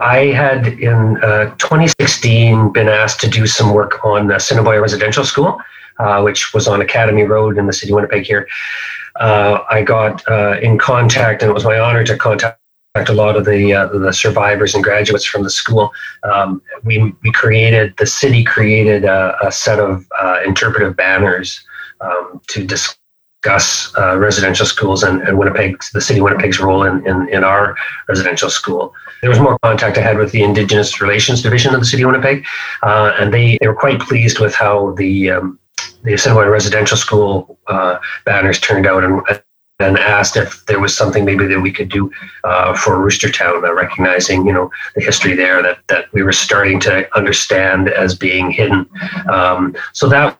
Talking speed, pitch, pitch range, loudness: 190 wpm, 105 Hz, 100-115 Hz, -12 LUFS